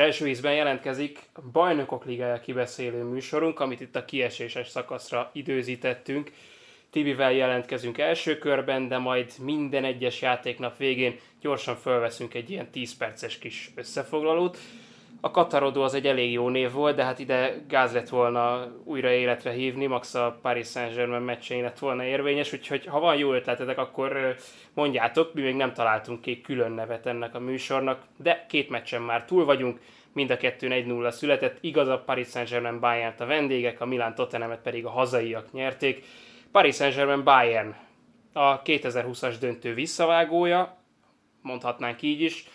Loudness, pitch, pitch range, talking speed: -27 LUFS, 130 Hz, 120-140 Hz, 155 wpm